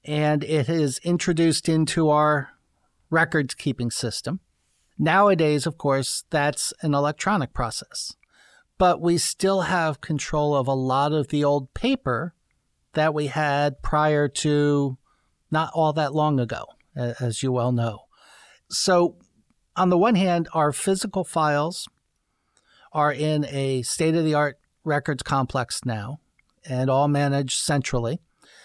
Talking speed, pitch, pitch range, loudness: 135 wpm, 150 Hz, 135-160 Hz, -23 LUFS